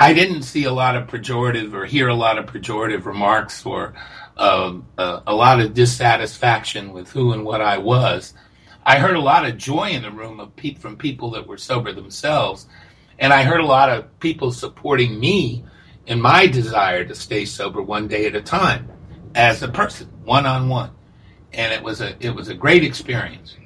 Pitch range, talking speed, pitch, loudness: 110-135 Hz, 200 wpm, 120 Hz, -18 LUFS